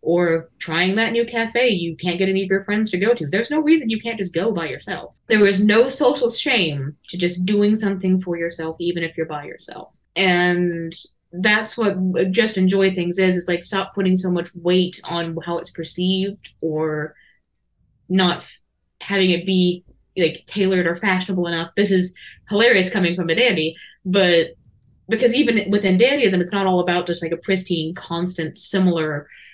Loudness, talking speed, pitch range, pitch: -19 LUFS, 185 wpm, 170-200 Hz, 180 Hz